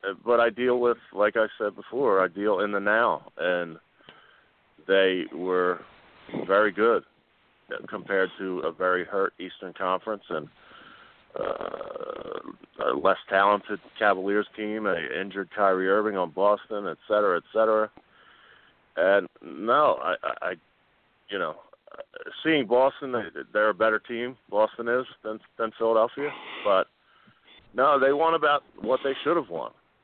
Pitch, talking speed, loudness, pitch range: 110 Hz, 140 wpm, -26 LUFS, 100-125 Hz